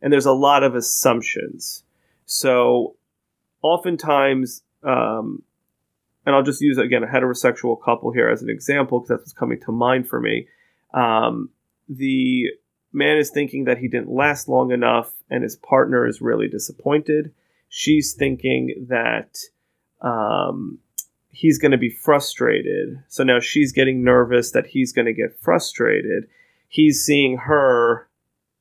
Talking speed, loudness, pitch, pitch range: 145 wpm, -19 LUFS, 140 Hz, 125-150 Hz